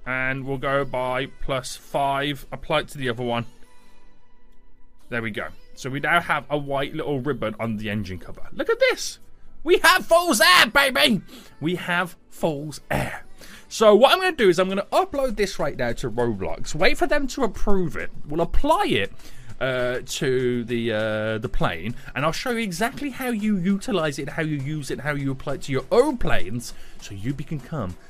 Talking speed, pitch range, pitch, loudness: 205 wpm, 125-195 Hz, 145 Hz, -23 LUFS